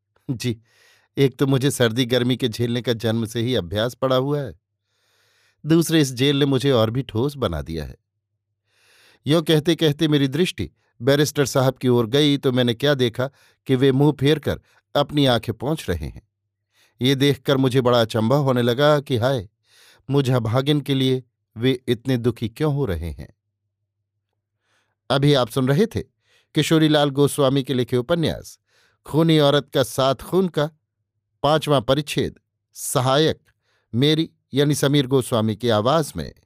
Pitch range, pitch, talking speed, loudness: 110-145 Hz, 130 Hz, 160 wpm, -20 LUFS